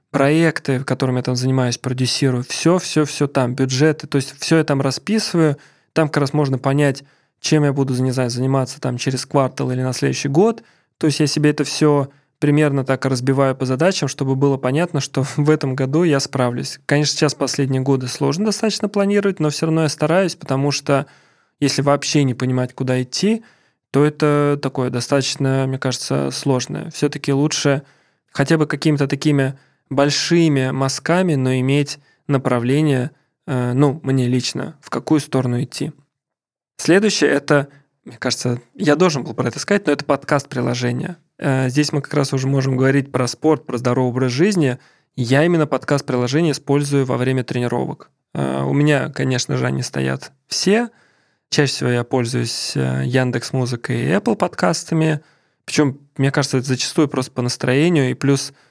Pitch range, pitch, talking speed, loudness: 130-150 Hz, 140 Hz, 165 wpm, -18 LUFS